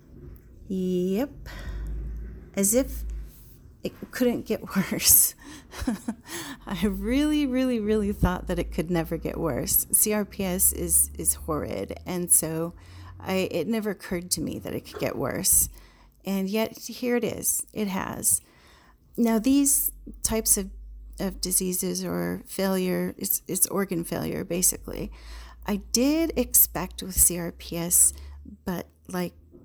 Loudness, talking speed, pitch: -24 LUFS, 125 wpm, 185 Hz